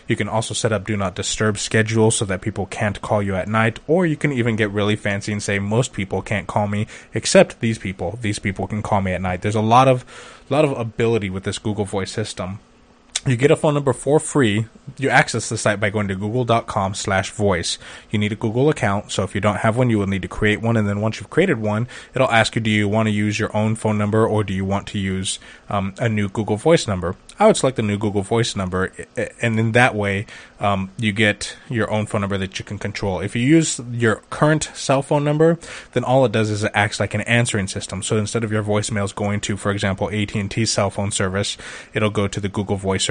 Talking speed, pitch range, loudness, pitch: 245 wpm, 100-115 Hz, -20 LUFS, 105 Hz